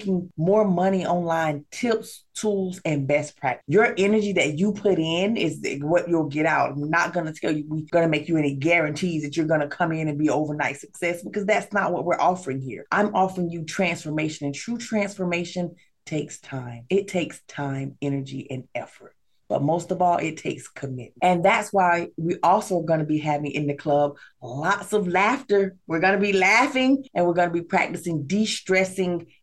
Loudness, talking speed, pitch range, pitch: -23 LUFS, 200 wpm, 150-190 Hz, 170 Hz